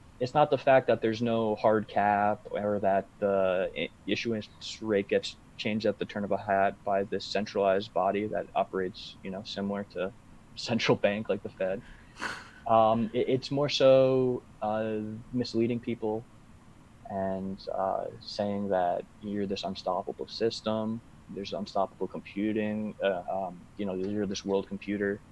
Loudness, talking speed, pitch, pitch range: -30 LUFS, 150 wpm, 105 Hz, 100-115 Hz